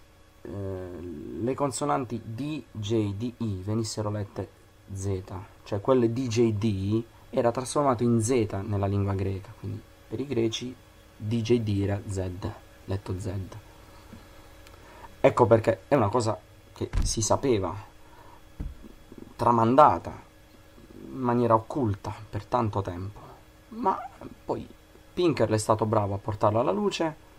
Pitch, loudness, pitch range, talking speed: 110 Hz, -27 LUFS, 100-120 Hz, 120 wpm